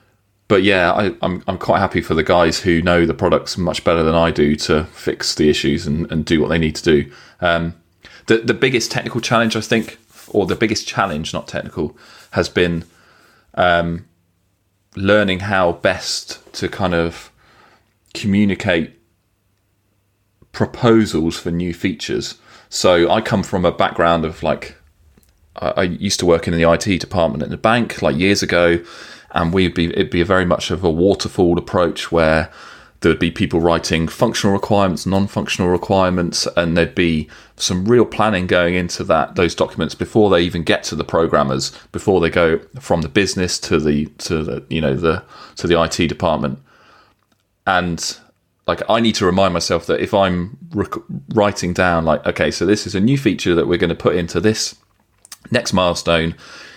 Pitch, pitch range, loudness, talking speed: 90 Hz, 85-100 Hz, -17 LUFS, 180 wpm